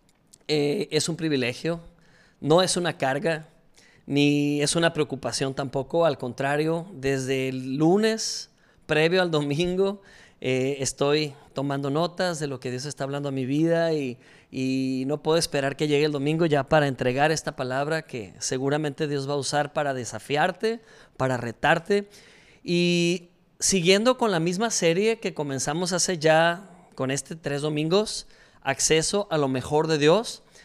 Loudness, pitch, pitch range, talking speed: -25 LUFS, 155 Hz, 140-170 Hz, 155 wpm